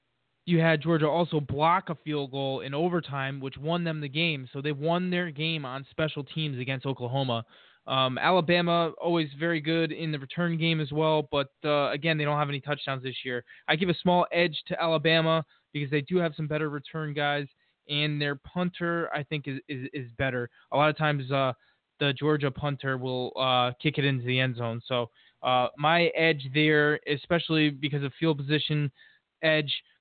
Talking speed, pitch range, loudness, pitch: 195 wpm, 135-160 Hz, -28 LUFS, 150 Hz